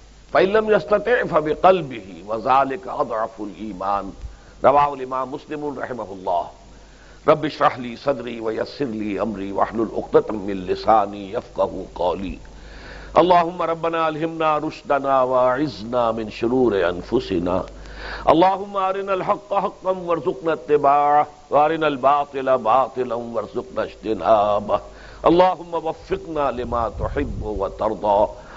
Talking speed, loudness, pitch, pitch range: 100 wpm, -21 LUFS, 145 Hz, 115-165 Hz